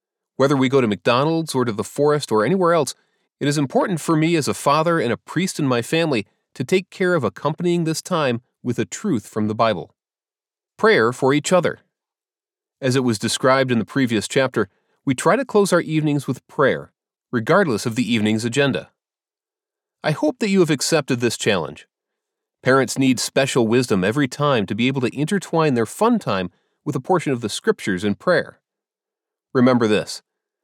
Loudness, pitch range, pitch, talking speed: -20 LUFS, 120-165 Hz, 140 Hz, 190 wpm